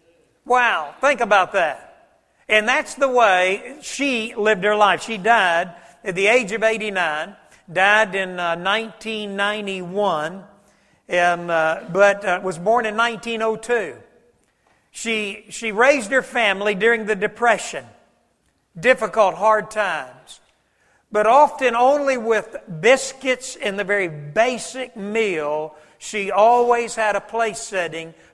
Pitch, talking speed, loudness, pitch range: 215 Hz, 125 wpm, -19 LUFS, 190-235 Hz